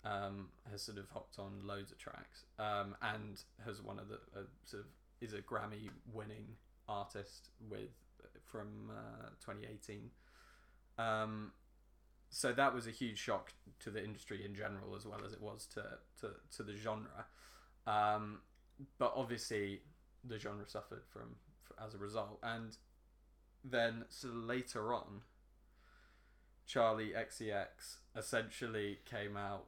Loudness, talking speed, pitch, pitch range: -44 LUFS, 140 wpm, 105 Hz, 100-115 Hz